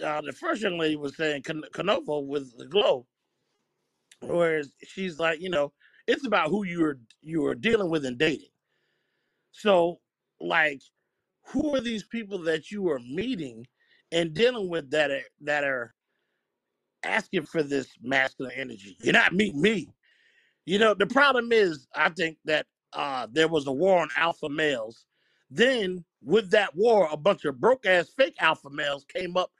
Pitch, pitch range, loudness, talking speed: 170 Hz, 150-210 Hz, -26 LUFS, 170 wpm